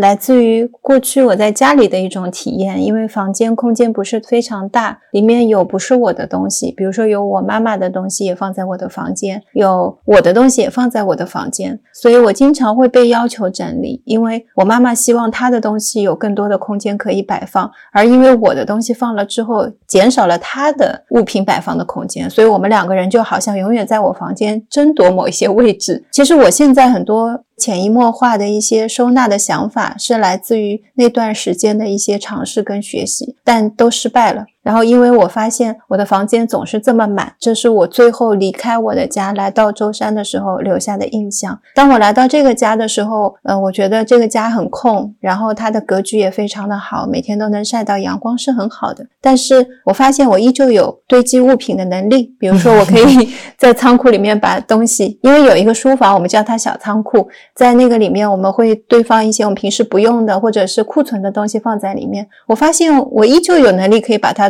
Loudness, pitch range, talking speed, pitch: -12 LUFS, 205-245 Hz, 325 characters per minute, 225 Hz